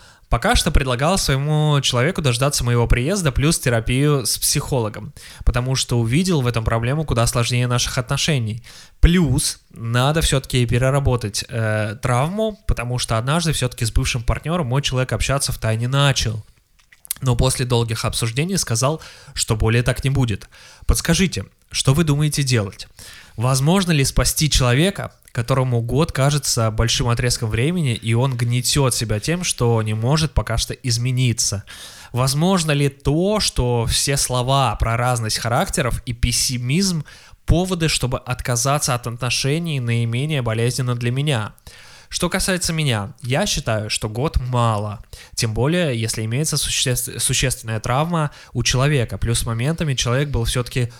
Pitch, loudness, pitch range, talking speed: 125 Hz, -19 LUFS, 115-145 Hz, 140 wpm